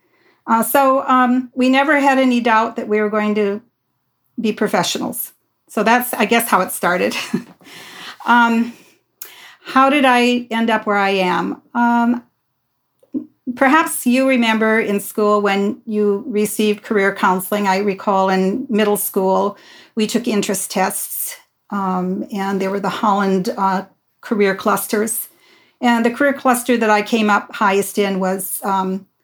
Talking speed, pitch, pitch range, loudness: 150 wpm, 220 Hz, 200-245 Hz, -17 LUFS